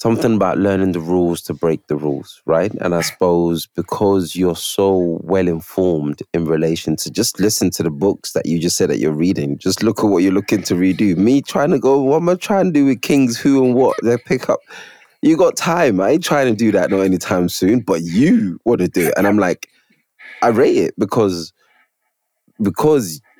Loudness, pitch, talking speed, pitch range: -16 LUFS, 95 Hz, 220 wpm, 85-120 Hz